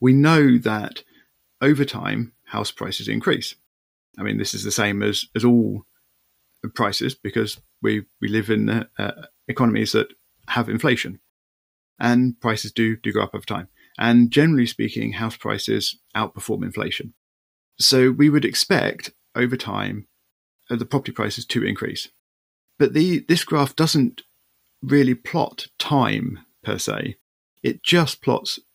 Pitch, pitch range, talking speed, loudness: 115 Hz, 105-130 Hz, 140 wpm, -21 LUFS